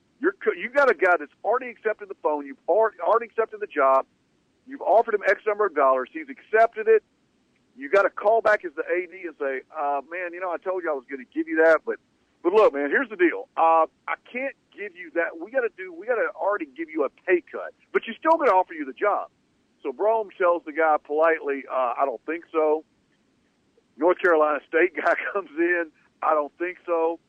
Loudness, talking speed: -24 LUFS, 235 wpm